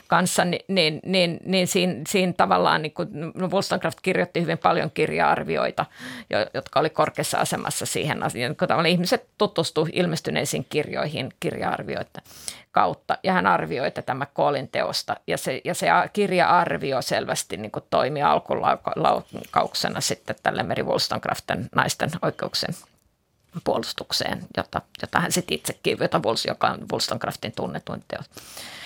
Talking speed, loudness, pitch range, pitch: 125 wpm, -24 LUFS, 160-185 Hz, 175 Hz